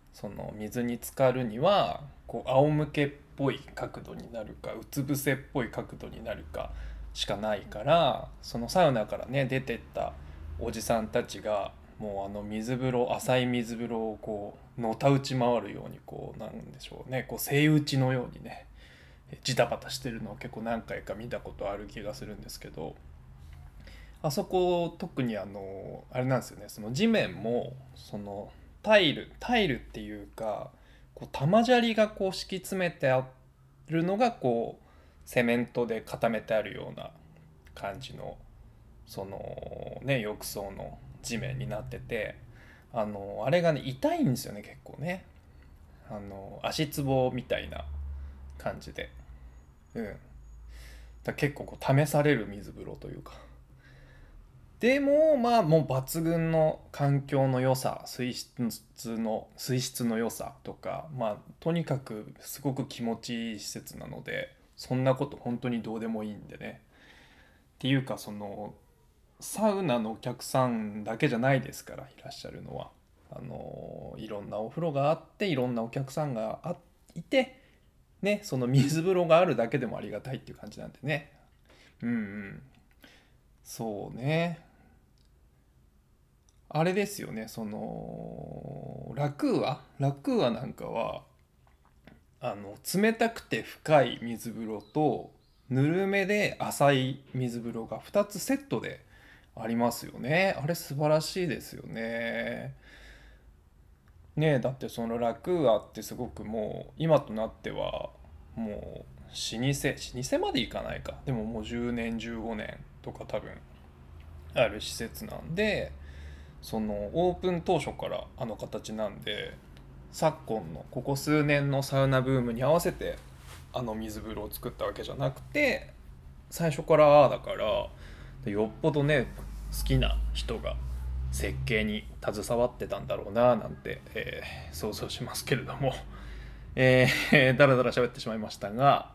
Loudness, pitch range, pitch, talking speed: -30 LUFS, 100-140 Hz, 120 Hz, 275 characters per minute